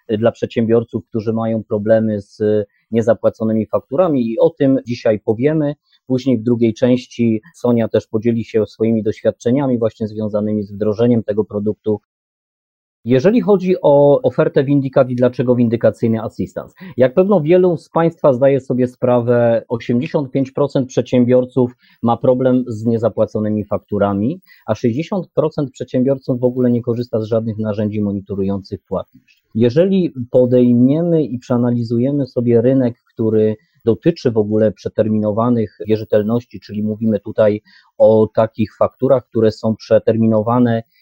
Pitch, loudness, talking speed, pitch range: 120 Hz, -16 LUFS, 125 wpm, 110-130 Hz